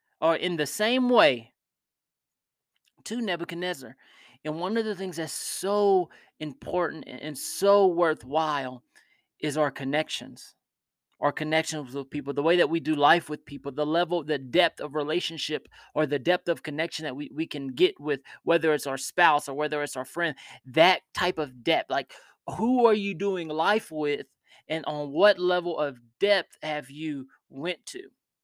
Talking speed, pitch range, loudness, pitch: 170 wpm, 150-180 Hz, -26 LUFS, 160 Hz